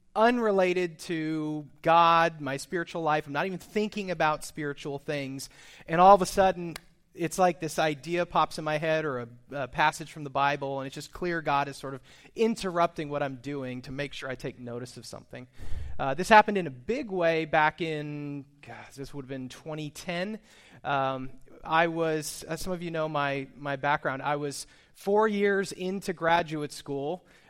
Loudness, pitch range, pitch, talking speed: -28 LUFS, 140-170 Hz, 155 Hz, 190 wpm